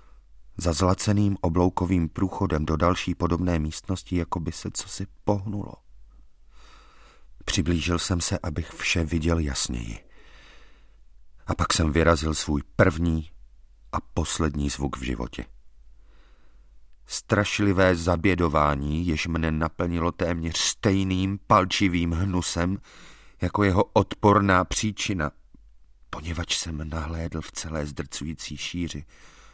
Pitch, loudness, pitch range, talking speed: 85 Hz, -25 LUFS, 75-90 Hz, 105 wpm